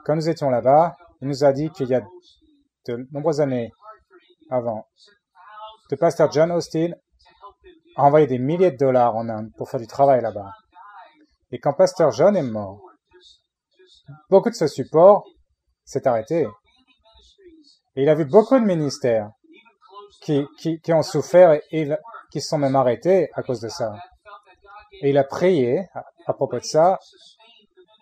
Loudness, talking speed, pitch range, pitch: -20 LUFS, 165 wpm, 135-205 Hz, 160 Hz